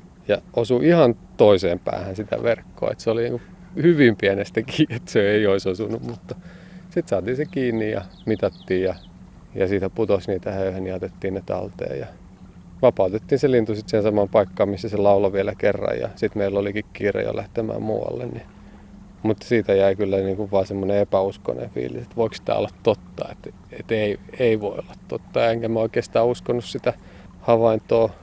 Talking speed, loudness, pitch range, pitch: 180 wpm, -22 LUFS, 95-115 Hz, 105 Hz